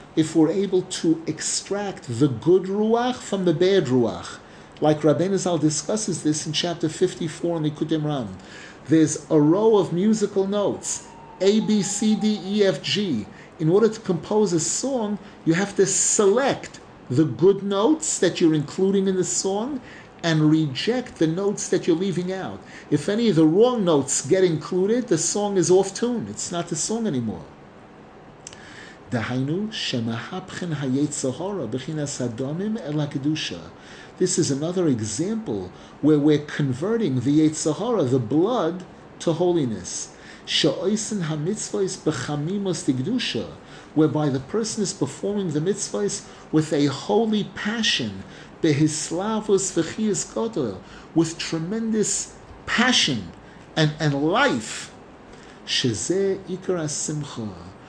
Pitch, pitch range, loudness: 170 Hz, 150-200 Hz, -22 LUFS